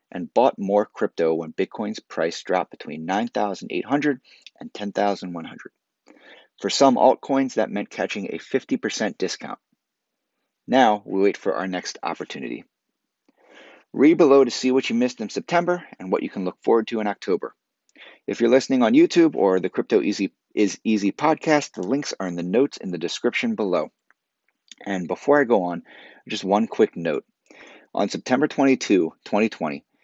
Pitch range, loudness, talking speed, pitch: 95-150 Hz, -22 LUFS, 160 wpm, 120 Hz